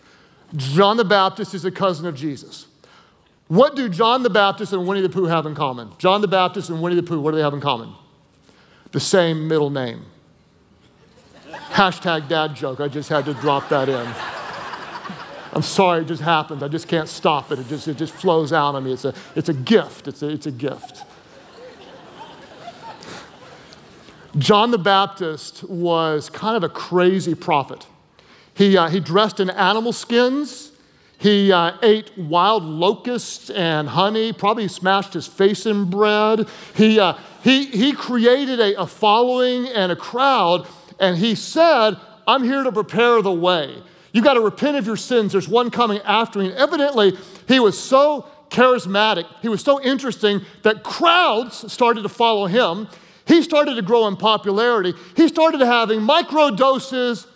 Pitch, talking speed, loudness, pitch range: 195 Hz, 170 wpm, -18 LUFS, 170-235 Hz